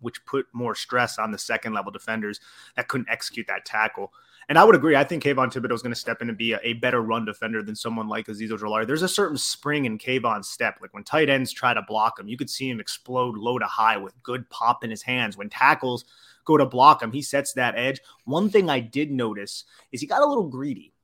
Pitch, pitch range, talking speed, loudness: 125 Hz, 110-135 Hz, 255 wpm, -23 LUFS